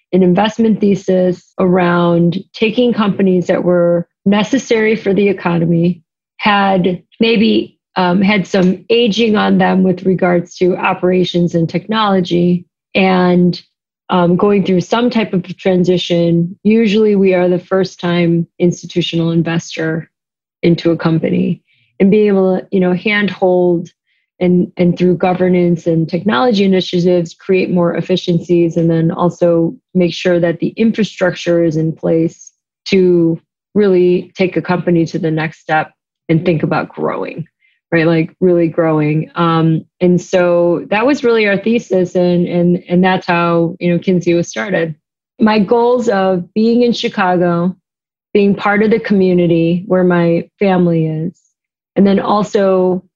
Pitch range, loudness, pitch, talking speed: 170-195 Hz, -13 LUFS, 180 Hz, 140 wpm